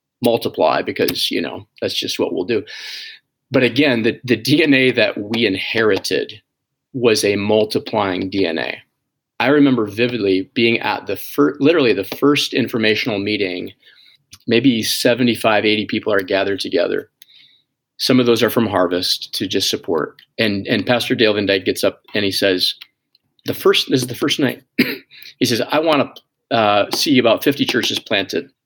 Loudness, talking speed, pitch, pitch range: -17 LUFS, 165 wpm, 115 Hz, 100-130 Hz